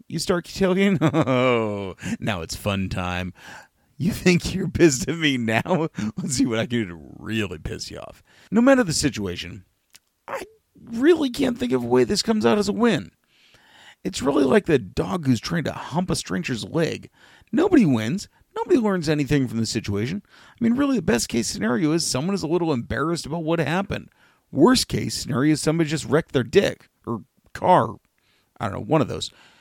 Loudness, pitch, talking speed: -22 LUFS, 155 Hz, 195 wpm